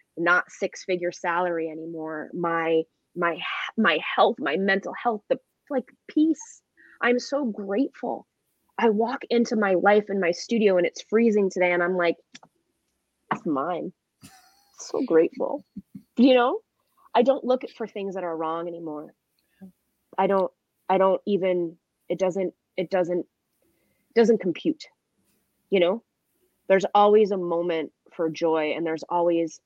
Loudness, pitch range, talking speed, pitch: -24 LUFS, 170-235 Hz, 140 wpm, 190 Hz